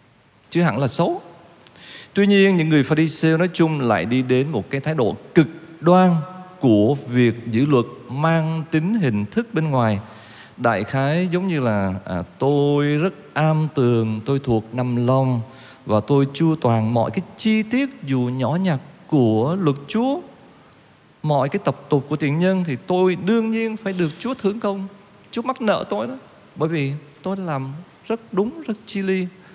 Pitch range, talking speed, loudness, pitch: 130-190 Hz, 180 wpm, -20 LUFS, 155 Hz